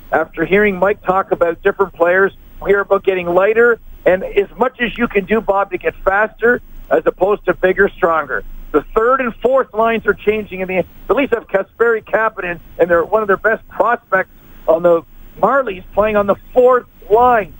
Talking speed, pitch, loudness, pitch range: 190 wpm, 200 Hz, -15 LUFS, 185-230 Hz